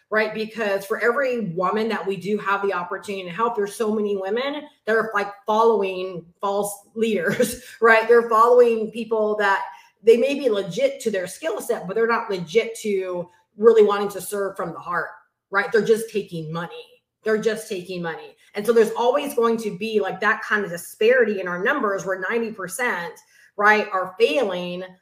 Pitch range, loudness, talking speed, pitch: 195-230 Hz, -22 LUFS, 185 wpm, 210 Hz